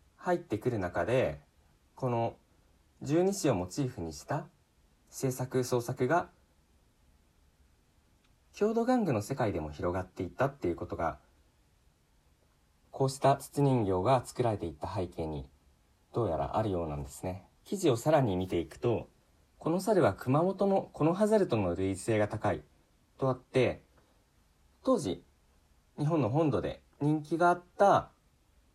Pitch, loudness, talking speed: 105 Hz, -31 LUFS, 265 characters per minute